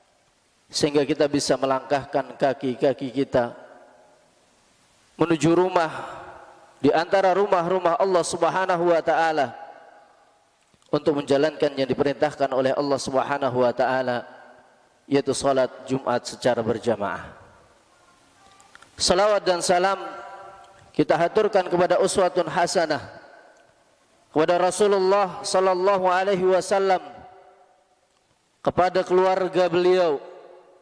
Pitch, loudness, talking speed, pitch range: 170 Hz, -22 LUFS, 90 wpm, 140-185 Hz